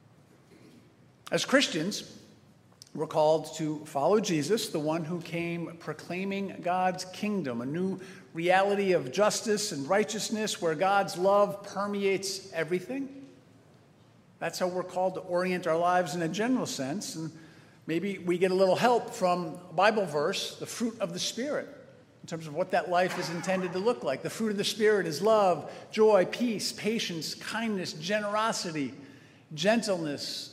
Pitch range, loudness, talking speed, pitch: 165-205 Hz, -29 LUFS, 155 wpm, 185 Hz